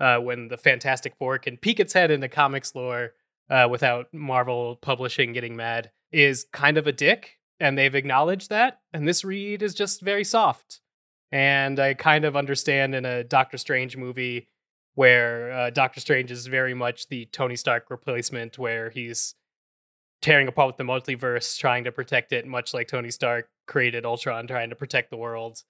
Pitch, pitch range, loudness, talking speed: 130 Hz, 120-140 Hz, -23 LUFS, 180 wpm